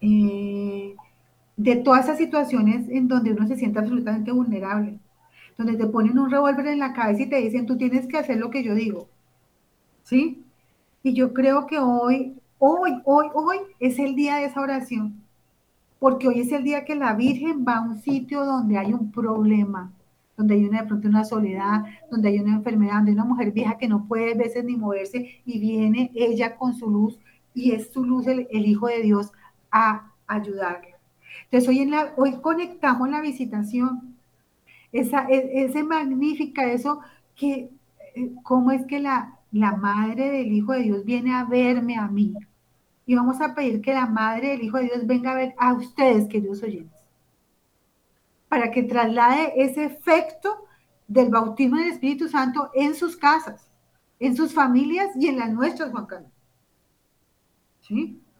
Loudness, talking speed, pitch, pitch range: -22 LUFS, 175 wpm, 250 Hz, 215-270 Hz